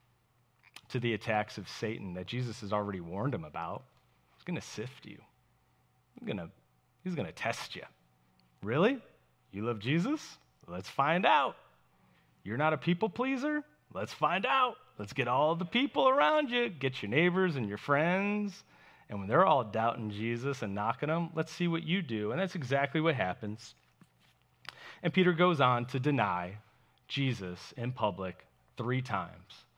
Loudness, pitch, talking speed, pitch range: -32 LUFS, 125 Hz, 160 wpm, 105-175 Hz